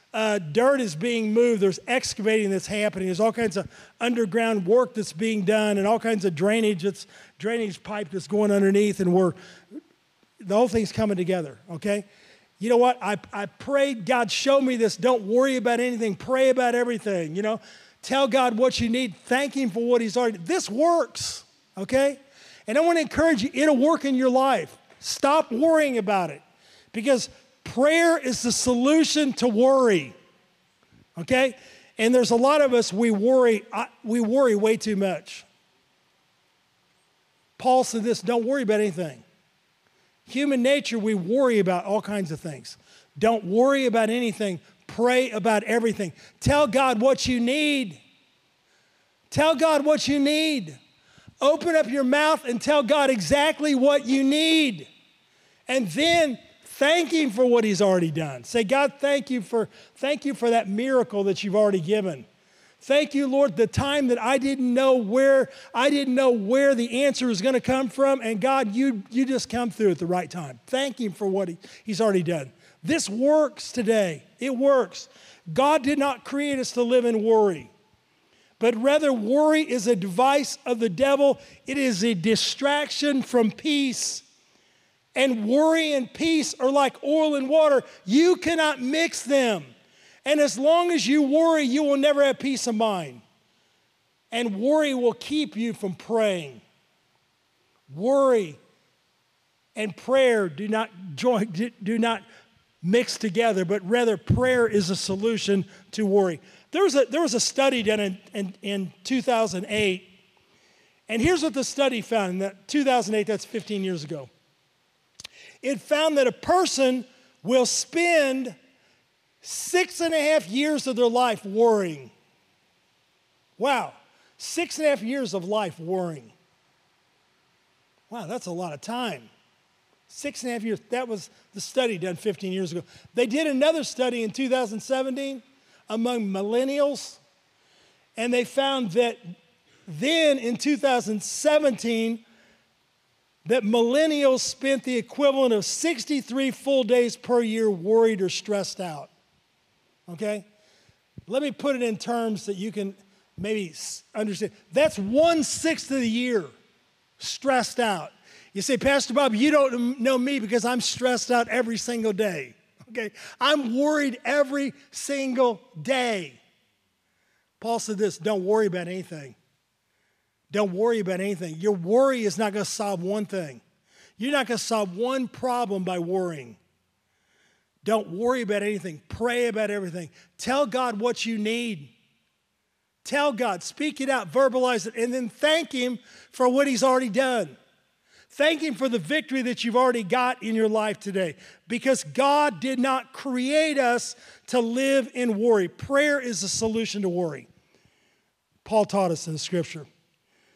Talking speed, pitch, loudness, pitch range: 155 wpm, 235 Hz, -23 LUFS, 205-270 Hz